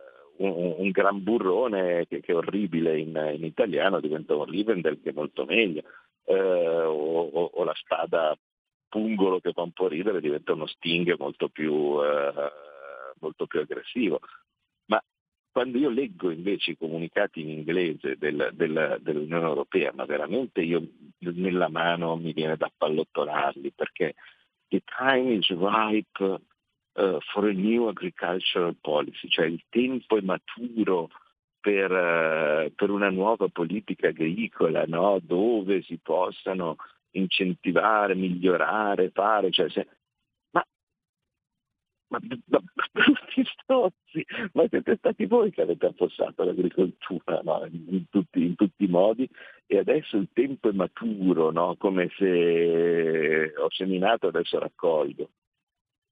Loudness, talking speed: -26 LUFS, 135 wpm